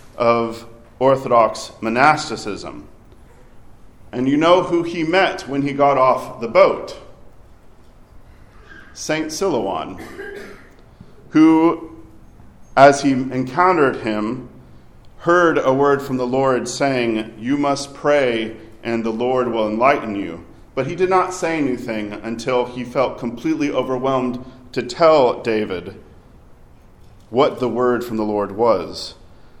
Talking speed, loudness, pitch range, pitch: 120 wpm, -18 LUFS, 115-155 Hz, 130 Hz